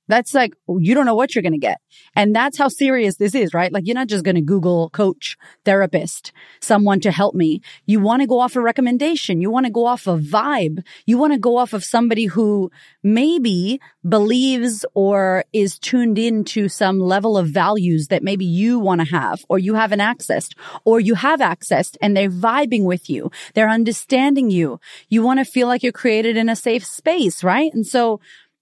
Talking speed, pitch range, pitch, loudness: 205 wpm, 190-245 Hz, 215 Hz, -17 LUFS